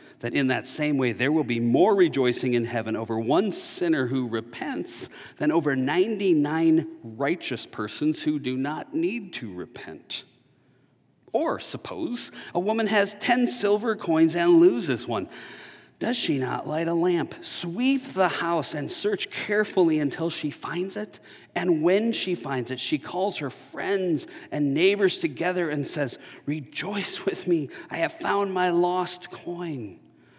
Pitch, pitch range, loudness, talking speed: 170 Hz, 145-200 Hz, -25 LUFS, 155 wpm